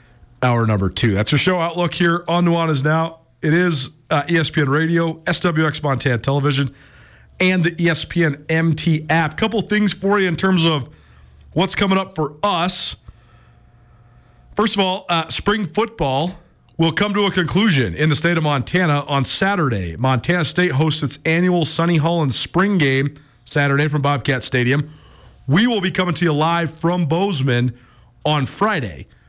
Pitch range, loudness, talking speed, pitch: 135-175 Hz, -18 LUFS, 160 wpm, 160 Hz